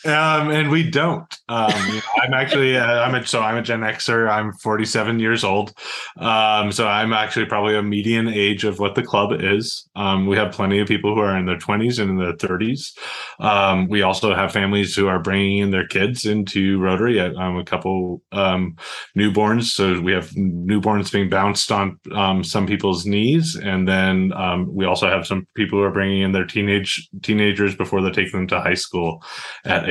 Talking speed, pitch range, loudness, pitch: 205 wpm, 95-110 Hz, -19 LUFS, 100 Hz